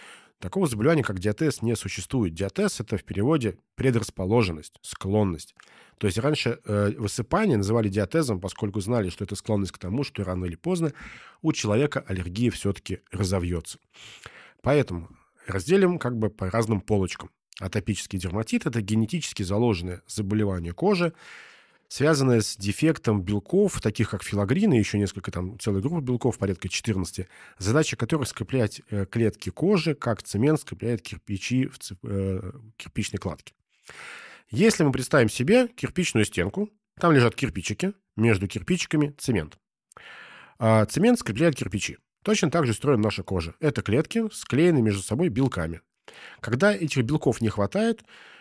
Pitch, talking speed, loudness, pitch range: 110 Hz, 135 wpm, -25 LUFS, 100-145 Hz